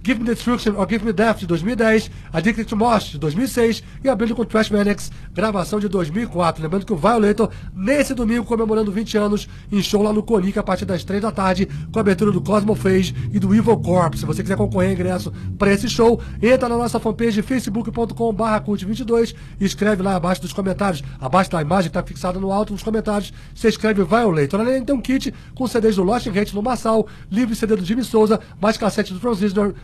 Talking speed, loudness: 215 wpm, -19 LUFS